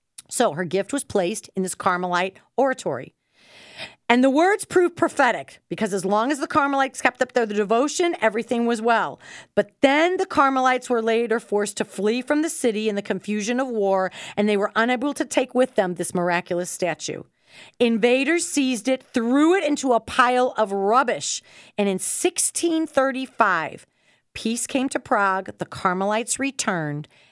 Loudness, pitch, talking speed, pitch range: -22 LUFS, 240 Hz, 165 wpm, 205-275 Hz